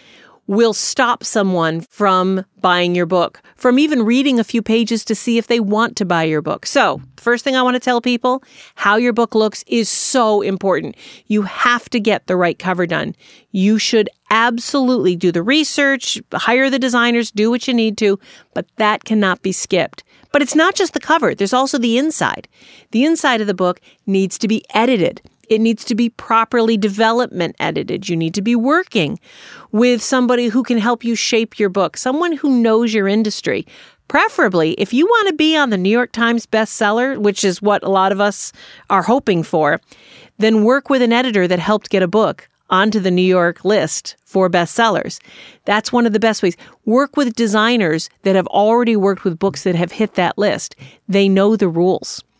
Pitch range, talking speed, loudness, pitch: 195-245 Hz, 195 wpm, -16 LUFS, 220 Hz